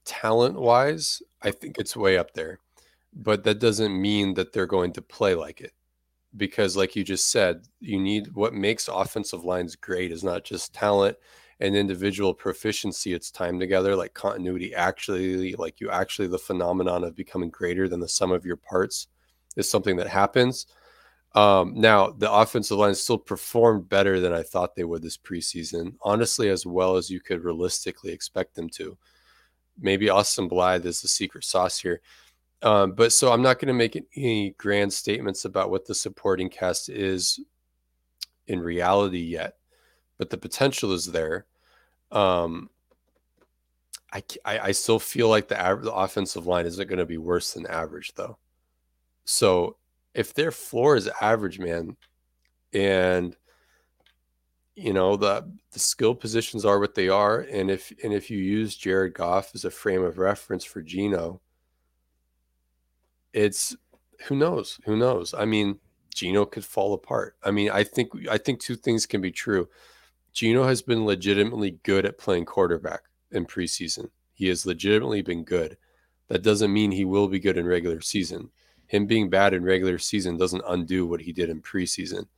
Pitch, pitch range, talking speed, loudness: 95 Hz, 85-105 Hz, 170 wpm, -25 LUFS